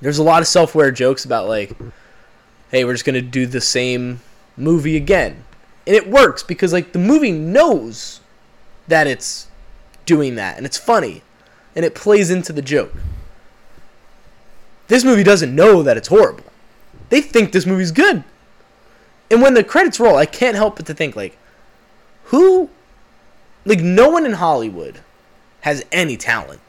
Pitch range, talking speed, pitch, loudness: 145-225 Hz, 160 wpm, 180 Hz, -14 LUFS